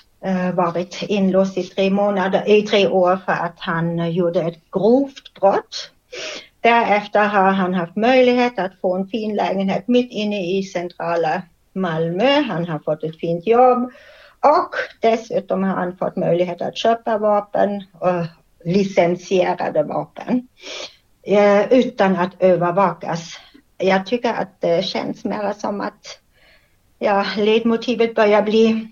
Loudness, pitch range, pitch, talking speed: -18 LUFS, 180-225 Hz, 195 Hz, 130 wpm